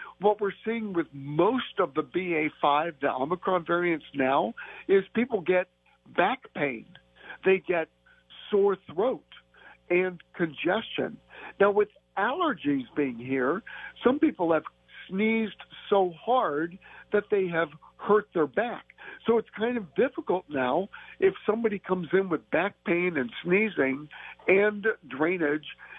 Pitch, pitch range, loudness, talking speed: 185 Hz, 160-215 Hz, -27 LUFS, 130 wpm